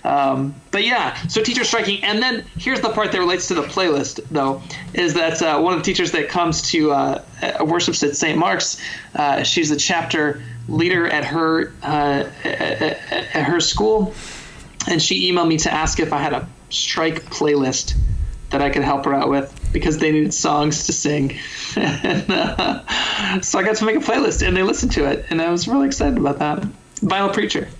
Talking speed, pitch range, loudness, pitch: 200 wpm, 145-195 Hz, -19 LUFS, 160 Hz